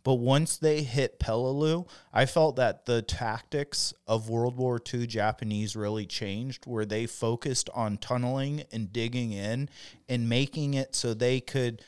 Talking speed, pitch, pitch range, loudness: 155 wpm, 125 Hz, 115-135 Hz, -29 LUFS